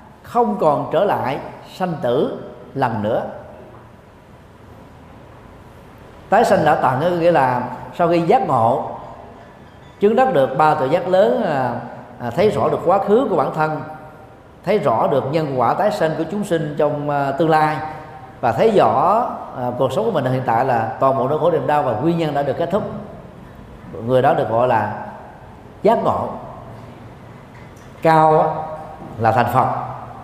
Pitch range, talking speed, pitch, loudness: 125-160 Hz, 160 wpm, 150 Hz, -18 LUFS